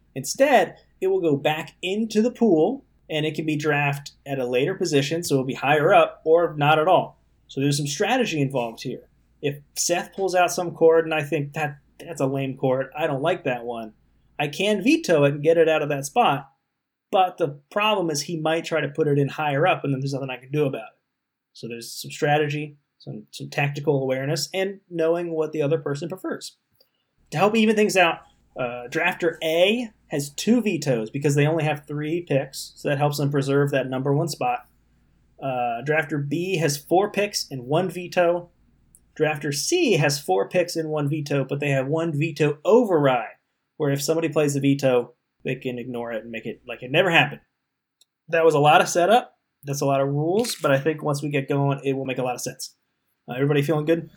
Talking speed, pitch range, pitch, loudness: 215 wpm, 140-165 Hz, 150 Hz, -23 LUFS